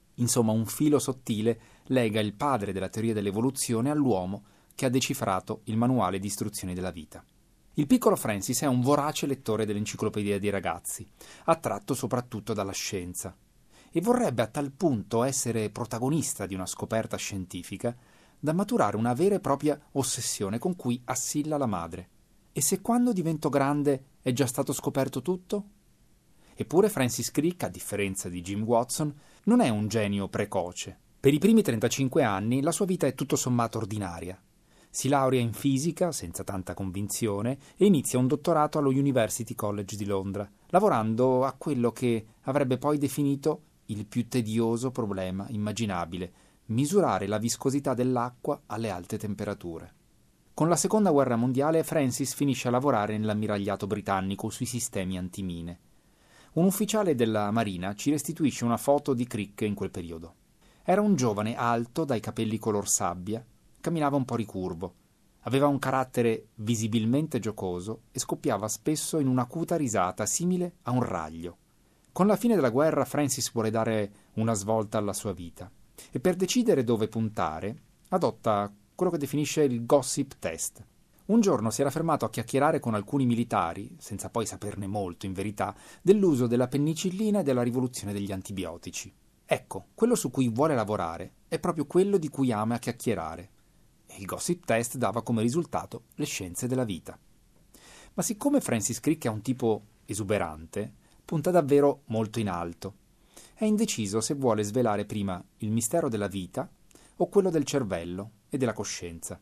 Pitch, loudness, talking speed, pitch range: 120 Hz, -28 LUFS, 155 wpm, 105-145 Hz